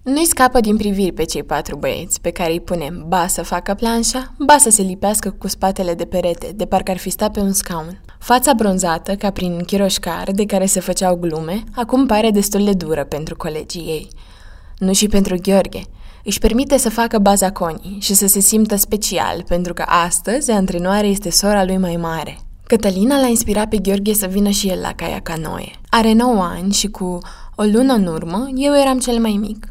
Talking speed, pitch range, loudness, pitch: 205 wpm, 175-215 Hz, -16 LUFS, 195 Hz